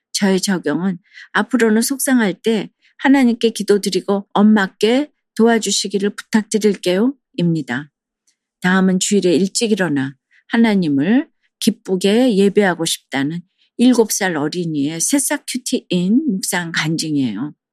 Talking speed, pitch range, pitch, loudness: 280 characters per minute, 180-235 Hz, 205 Hz, -17 LUFS